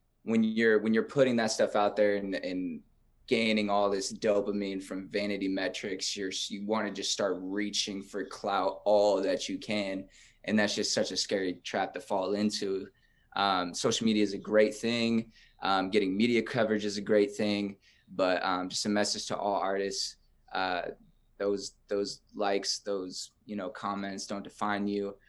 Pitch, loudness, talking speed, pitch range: 105 Hz, -30 LUFS, 180 wpm, 100-110 Hz